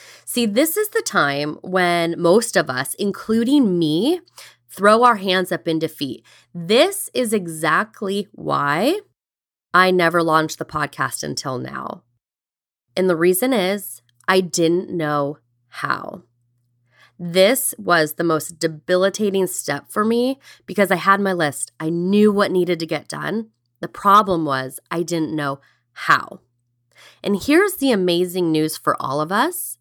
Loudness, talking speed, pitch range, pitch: -19 LUFS, 145 wpm, 150-205 Hz, 175 Hz